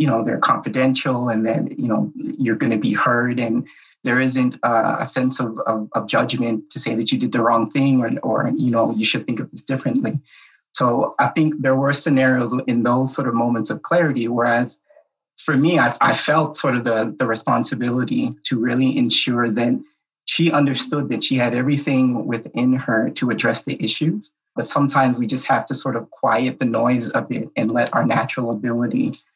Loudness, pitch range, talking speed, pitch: -19 LUFS, 115-135 Hz, 200 wpm, 125 Hz